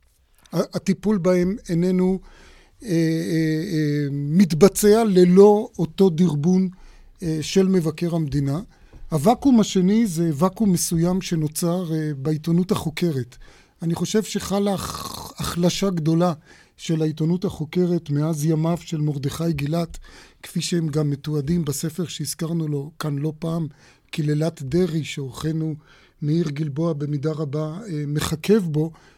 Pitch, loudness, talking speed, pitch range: 165 Hz, -22 LUFS, 115 wpm, 155-185 Hz